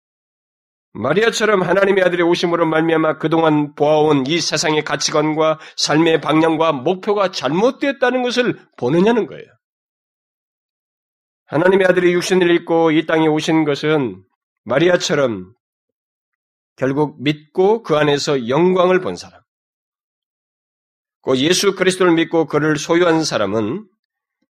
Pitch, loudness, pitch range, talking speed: 165 Hz, -16 LUFS, 155-185 Hz, 275 characters per minute